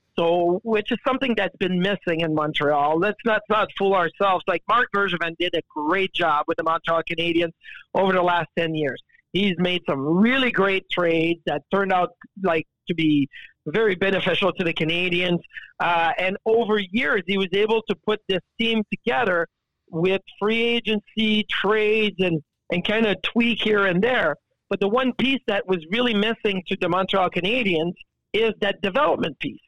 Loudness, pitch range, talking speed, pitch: -22 LUFS, 170-215 Hz, 180 wpm, 190 Hz